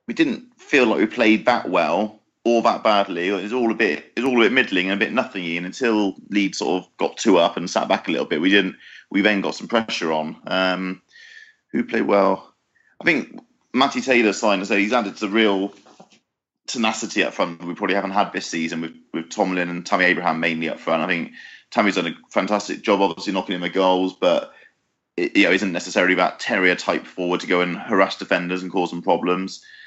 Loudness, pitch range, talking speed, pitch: -20 LUFS, 90-105 Hz, 225 wpm, 95 Hz